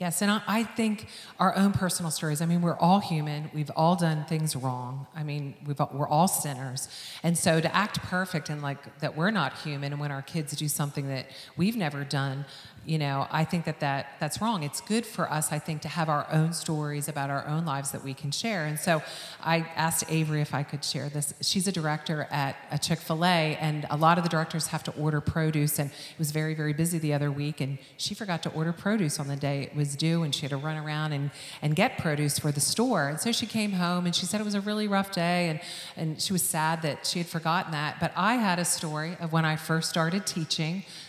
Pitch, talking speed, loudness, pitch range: 155 Hz, 245 wpm, -28 LUFS, 145-170 Hz